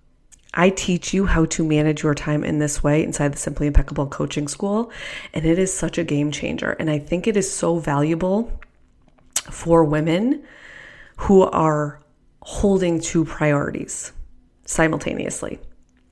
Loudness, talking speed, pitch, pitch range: -21 LUFS, 145 wpm, 160 Hz, 150-185 Hz